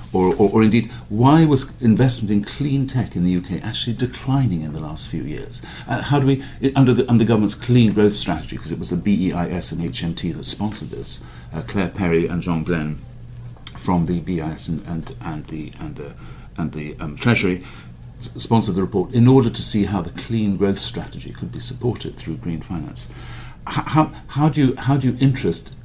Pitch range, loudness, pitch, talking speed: 90-125 Hz, -20 LUFS, 110 Hz, 210 wpm